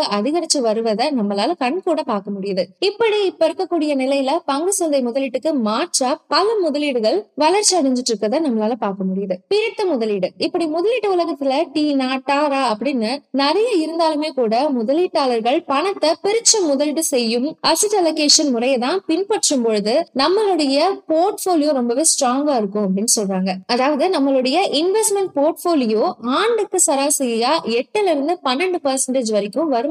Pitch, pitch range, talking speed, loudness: 290 Hz, 245-340 Hz, 120 wpm, -18 LUFS